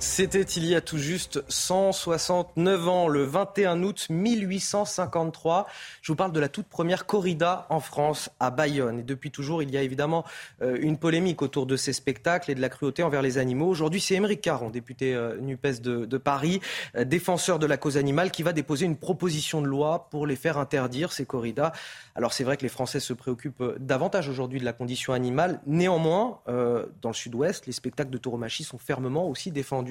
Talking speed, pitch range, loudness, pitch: 195 wpm, 135-175 Hz, -27 LUFS, 150 Hz